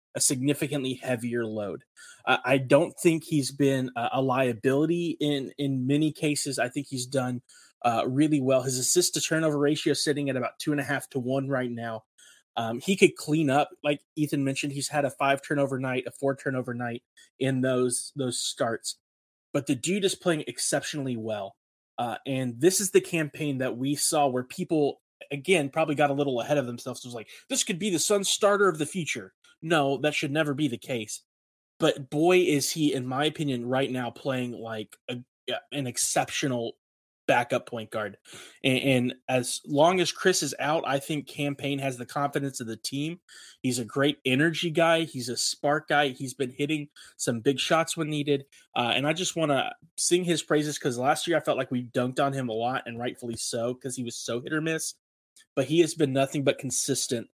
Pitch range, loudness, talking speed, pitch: 125-150 Hz, -27 LUFS, 205 wpm, 140 Hz